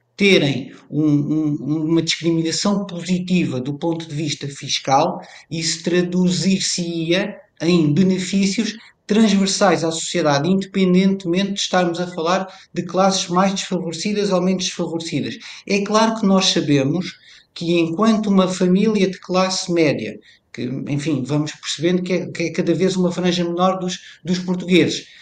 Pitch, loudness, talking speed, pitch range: 180 Hz, -19 LUFS, 140 wpm, 165-190 Hz